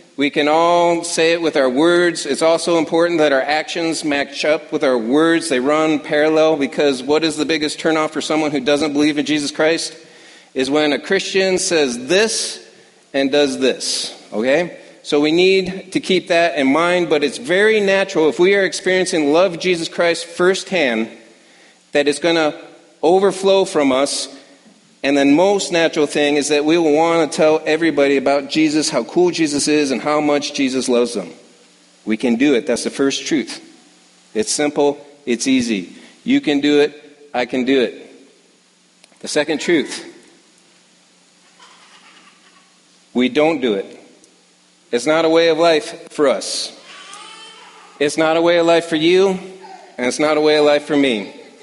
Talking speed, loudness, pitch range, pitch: 175 wpm, -16 LUFS, 145-170 Hz, 155 Hz